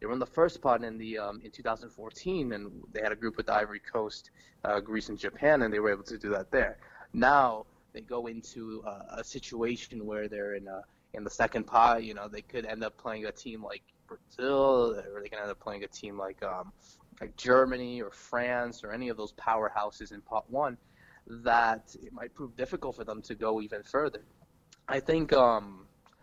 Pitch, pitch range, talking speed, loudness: 115 Hz, 105-120 Hz, 215 wpm, -31 LUFS